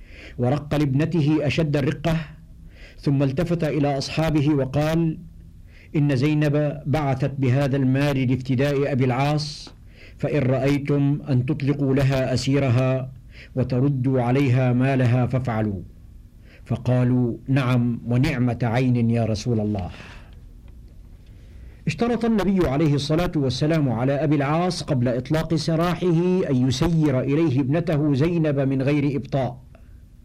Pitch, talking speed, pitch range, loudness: 135 Hz, 105 wpm, 120-150 Hz, -22 LUFS